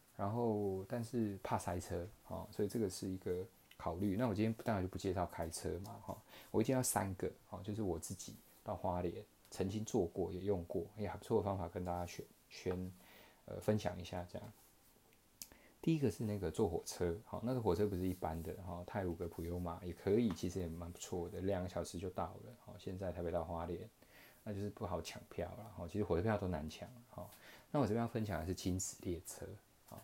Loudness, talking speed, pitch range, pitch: -41 LUFS, 320 characters per minute, 85-105 Hz, 95 Hz